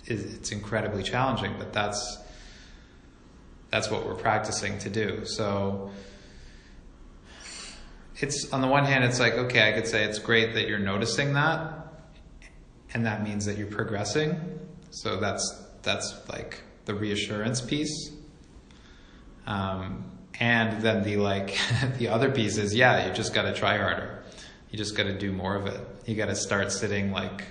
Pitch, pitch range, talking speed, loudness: 105 Hz, 100-115 Hz, 150 wpm, -27 LUFS